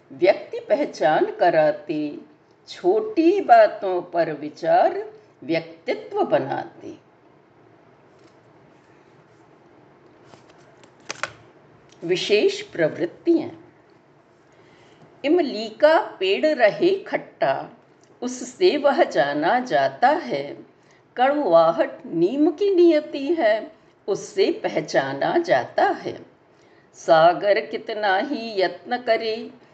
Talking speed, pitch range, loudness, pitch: 65 wpm, 255-355 Hz, -21 LUFS, 325 Hz